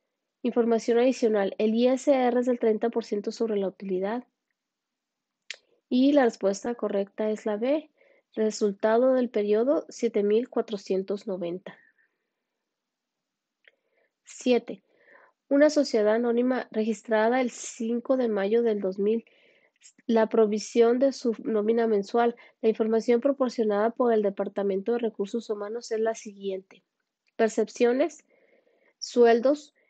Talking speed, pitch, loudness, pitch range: 105 wpm, 230 Hz, -26 LUFS, 215-255 Hz